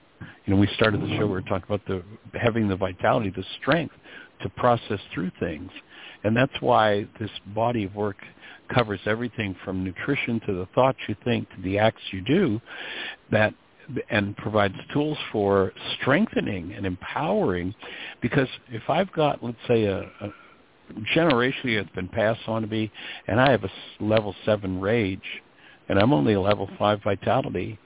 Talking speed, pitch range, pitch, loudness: 170 wpm, 95-115 Hz, 105 Hz, -25 LUFS